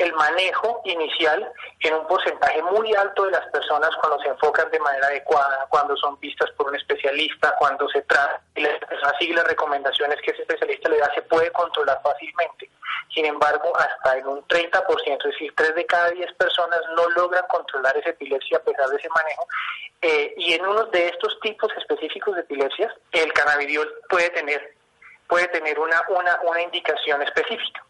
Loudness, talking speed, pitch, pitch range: -21 LUFS, 180 wpm, 175 Hz, 150-220 Hz